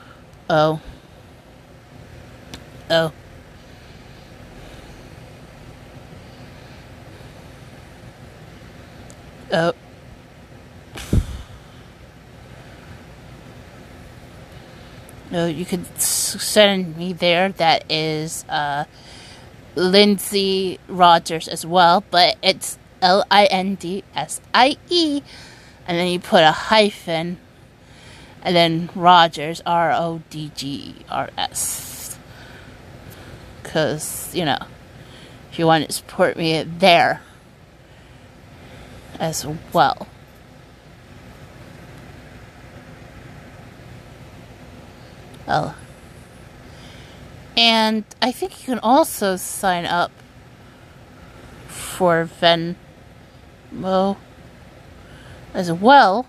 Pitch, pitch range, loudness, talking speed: 160 Hz, 125-180 Hz, -18 LUFS, 65 wpm